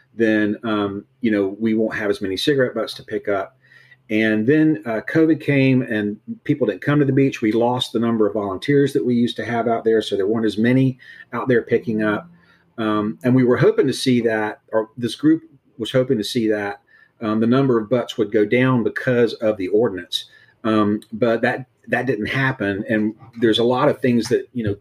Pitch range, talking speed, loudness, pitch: 110-130 Hz, 220 wpm, -20 LUFS, 115 Hz